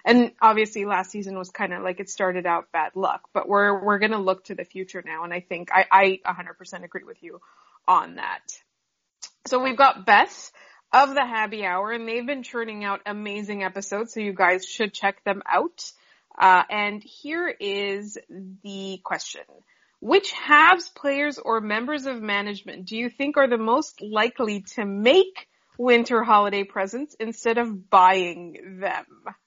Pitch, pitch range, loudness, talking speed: 210 Hz, 190-240 Hz, -22 LUFS, 170 wpm